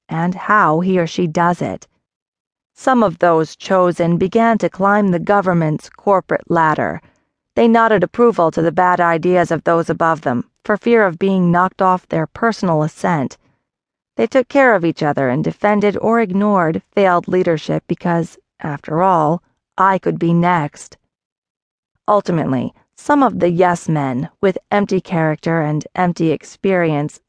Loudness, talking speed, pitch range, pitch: -16 LUFS, 150 wpm, 165-200 Hz, 180 Hz